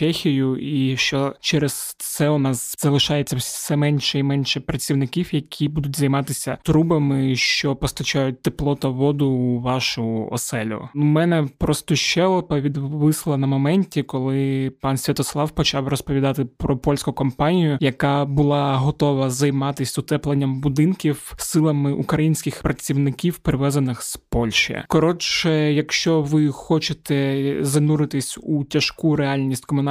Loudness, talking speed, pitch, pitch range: -20 LUFS, 120 wpm, 145 Hz, 135-150 Hz